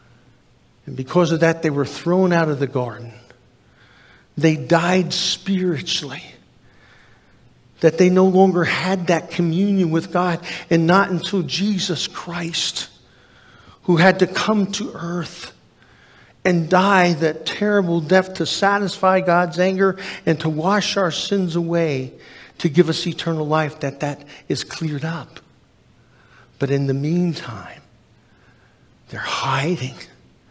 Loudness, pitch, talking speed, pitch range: -19 LUFS, 170 Hz, 130 wpm, 145-185 Hz